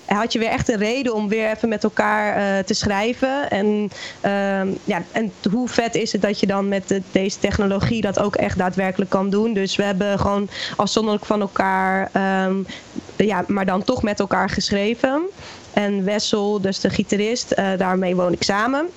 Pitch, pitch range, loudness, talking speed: 205 Hz, 195-220 Hz, -20 LUFS, 190 wpm